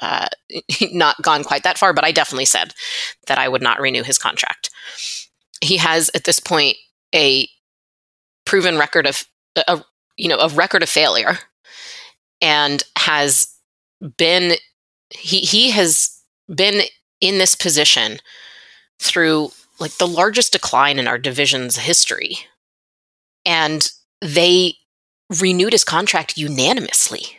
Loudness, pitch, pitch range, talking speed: -15 LUFS, 165 Hz, 145-190 Hz, 125 wpm